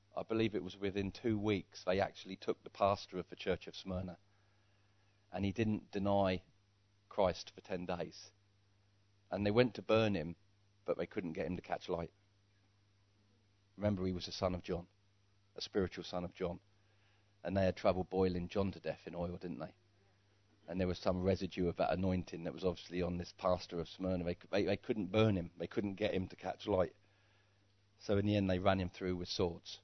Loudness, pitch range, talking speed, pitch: -38 LUFS, 90-100 Hz, 205 wpm, 100 Hz